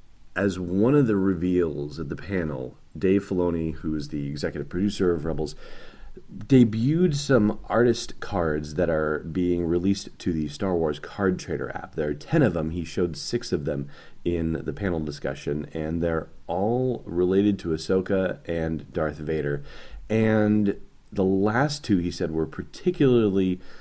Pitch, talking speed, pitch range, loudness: 90 Hz, 160 wpm, 80-100 Hz, -25 LUFS